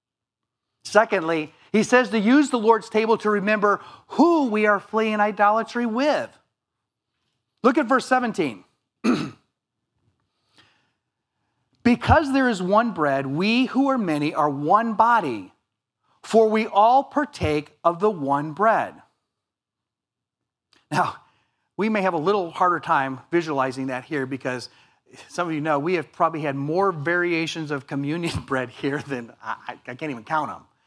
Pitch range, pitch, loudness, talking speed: 140-225 Hz, 180 Hz, -22 LUFS, 140 wpm